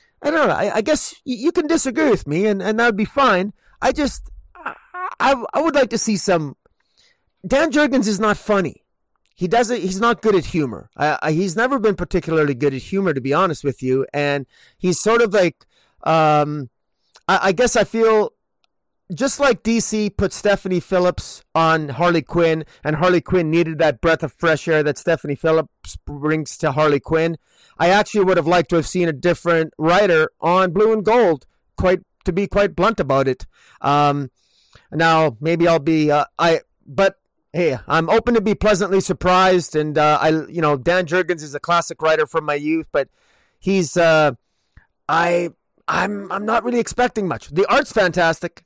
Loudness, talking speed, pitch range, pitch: -18 LUFS, 185 wpm, 155-210 Hz, 175 Hz